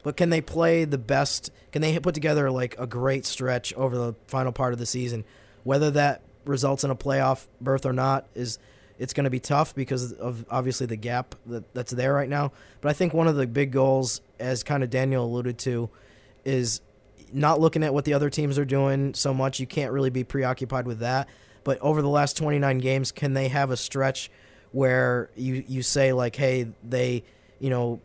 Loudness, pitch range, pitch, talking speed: -25 LUFS, 125-140 Hz, 130 Hz, 210 wpm